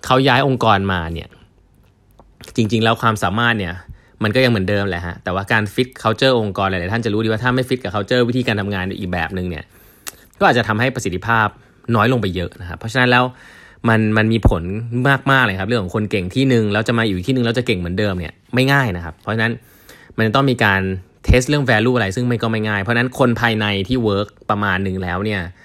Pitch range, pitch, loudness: 95-125 Hz, 110 Hz, -17 LUFS